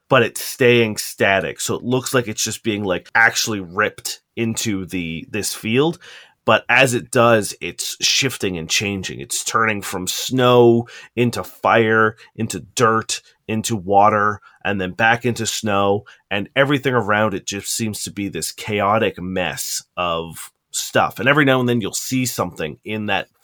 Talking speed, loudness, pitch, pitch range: 165 wpm, -19 LUFS, 110 Hz, 100-120 Hz